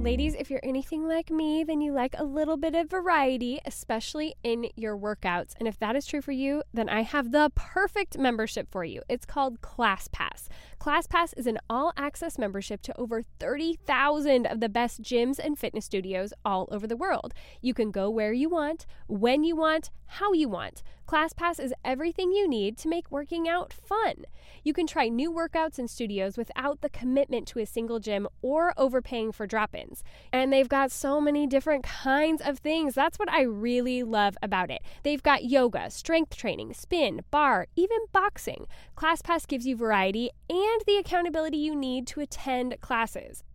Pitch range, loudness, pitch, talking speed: 235-315 Hz, -28 LUFS, 275 Hz, 180 wpm